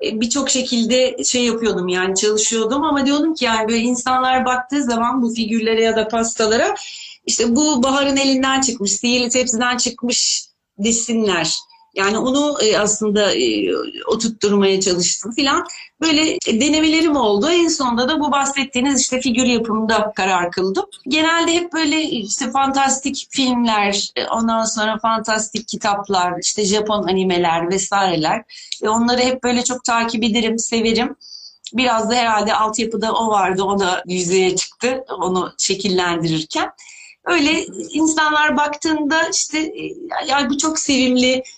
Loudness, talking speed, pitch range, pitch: -17 LUFS, 130 wpm, 215-280 Hz, 245 Hz